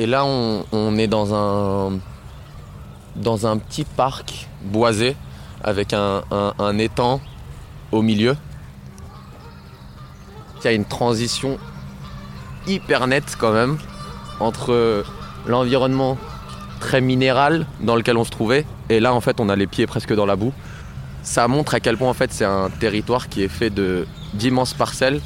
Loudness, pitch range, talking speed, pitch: -20 LUFS, 95-125 Hz, 155 wpm, 110 Hz